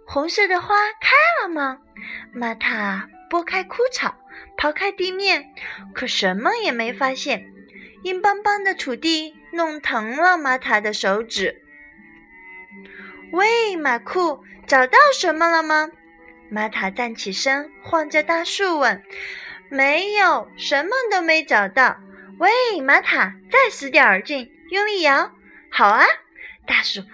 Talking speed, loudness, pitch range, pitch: 175 characters per minute, -19 LUFS, 230-370 Hz, 300 Hz